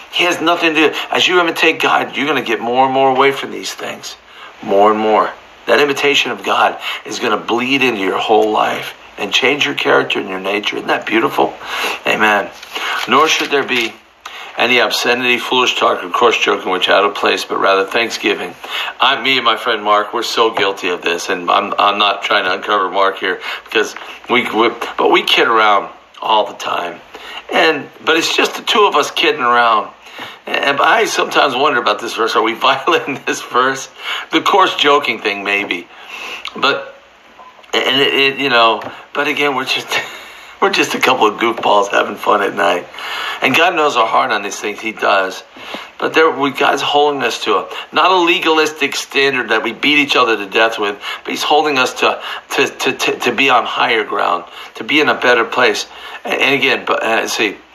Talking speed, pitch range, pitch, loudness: 200 wpm, 105-145 Hz, 125 Hz, -14 LUFS